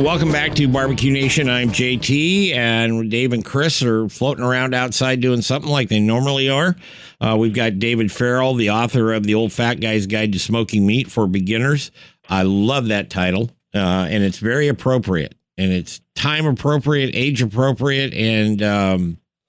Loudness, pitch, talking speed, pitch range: -18 LUFS, 120 Hz, 170 wpm, 110-135 Hz